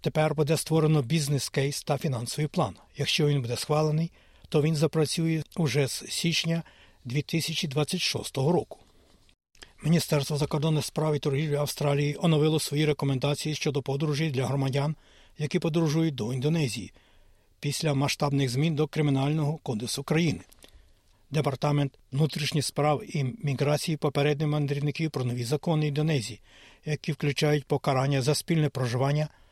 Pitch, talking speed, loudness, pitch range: 150 Hz, 120 wpm, -27 LUFS, 140-155 Hz